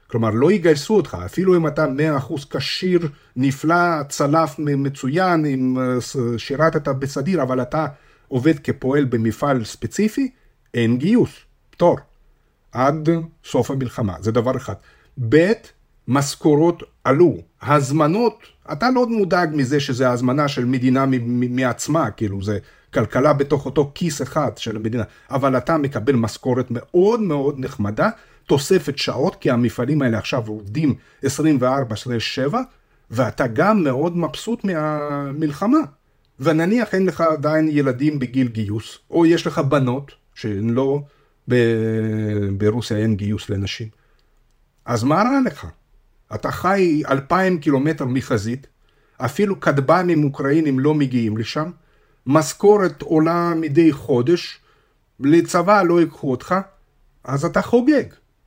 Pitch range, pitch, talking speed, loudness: 125-165 Hz, 140 Hz, 125 wpm, -19 LUFS